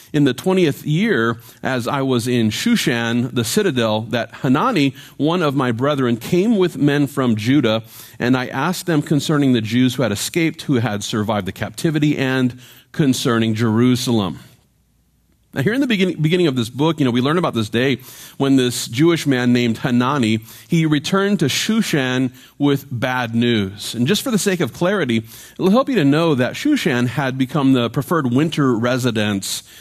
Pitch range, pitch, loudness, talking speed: 120-155 Hz, 130 Hz, -18 LUFS, 180 wpm